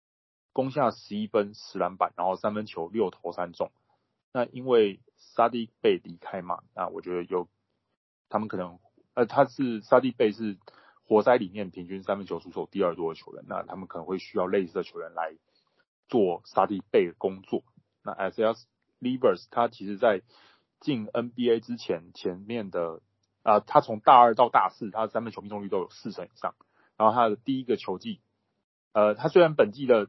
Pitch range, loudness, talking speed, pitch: 95-120 Hz, -27 LUFS, 280 characters per minute, 110 Hz